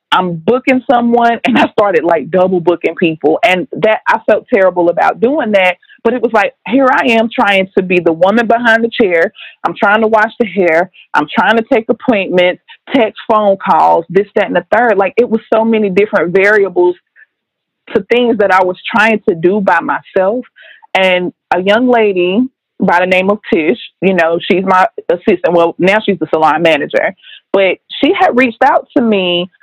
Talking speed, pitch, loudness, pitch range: 195 wpm, 205 Hz, -11 LUFS, 185-235 Hz